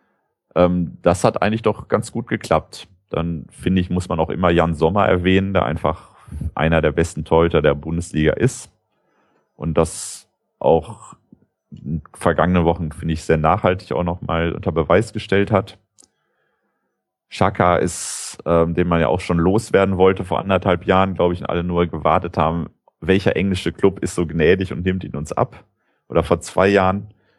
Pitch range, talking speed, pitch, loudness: 80-95 Hz, 170 wpm, 90 Hz, -19 LUFS